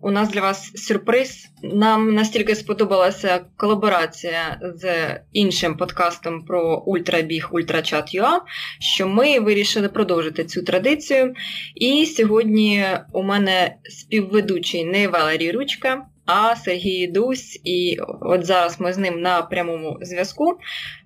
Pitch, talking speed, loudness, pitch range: 190 Hz, 115 wpm, -20 LUFS, 175-215 Hz